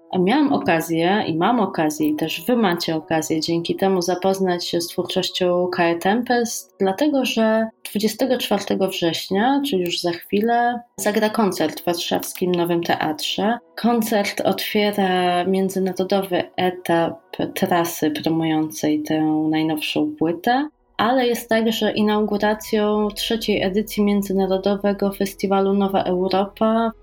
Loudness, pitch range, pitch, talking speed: -20 LUFS, 170-215 Hz, 190 Hz, 115 wpm